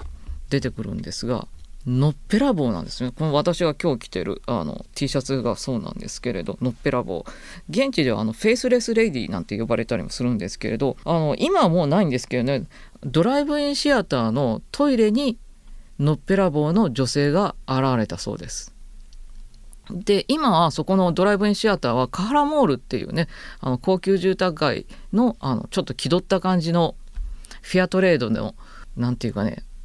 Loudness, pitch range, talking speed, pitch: -22 LUFS, 125-200 Hz, 360 characters per minute, 155 Hz